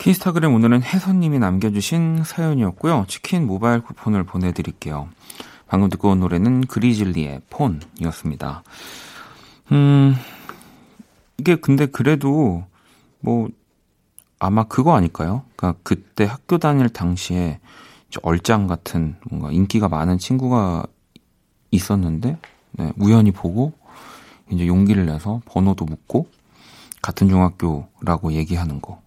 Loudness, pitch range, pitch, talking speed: -19 LUFS, 85-130 Hz, 100 Hz, 275 characters per minute